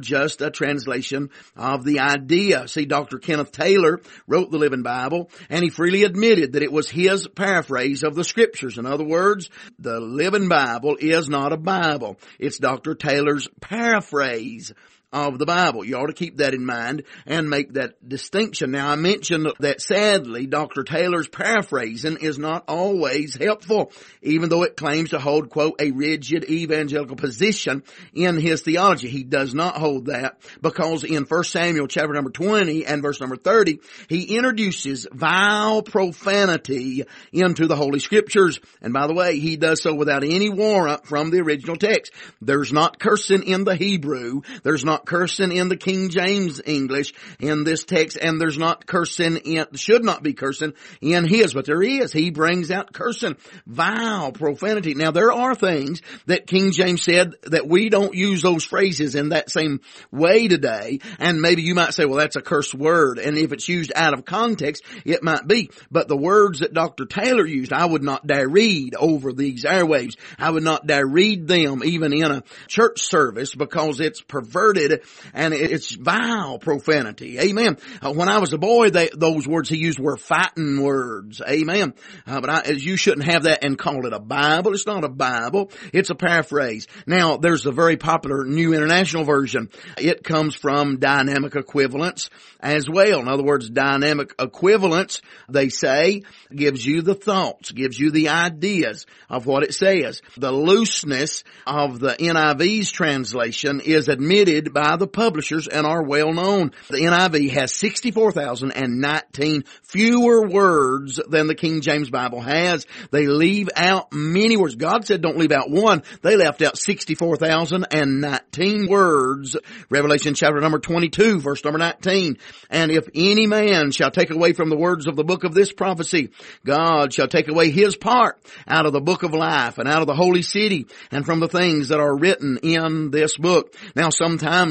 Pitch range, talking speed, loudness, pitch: 145-185 Hz, 175 wpm, -20 LUFS, 160 Hz